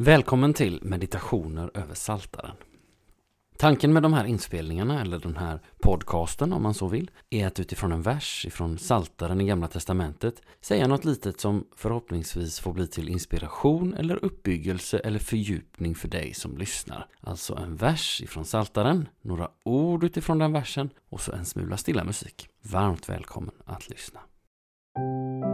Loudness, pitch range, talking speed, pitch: -27 LUFS, 85-130 Hz, 155 wpm, 100 Hz